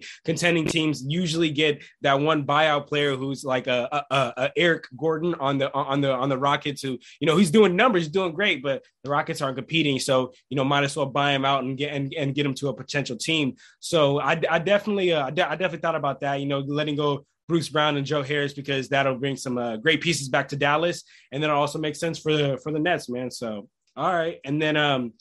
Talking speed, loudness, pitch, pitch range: 245 wpm, -24 LUFS, 145 Hz, 135-160 Hz